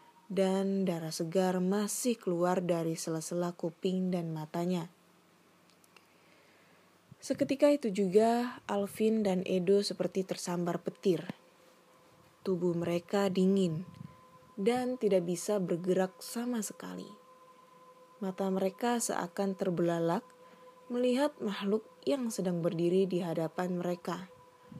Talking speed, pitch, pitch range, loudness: 95 wpm, 190 Hz, 175-215 Hz, -32 LUFS